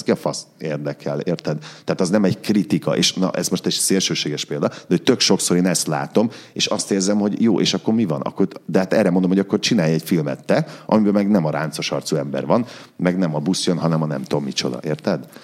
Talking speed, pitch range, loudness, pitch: 240 wpm, 75-100 Hz, -20 LUFS, 90 Hz